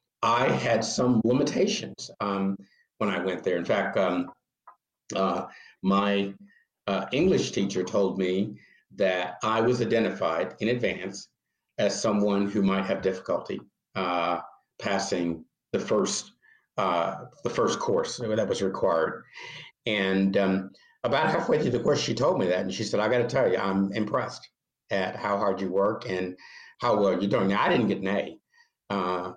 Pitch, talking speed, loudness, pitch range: 100 Hz, 165 wpm, -27 LUFS, 95-105 Hz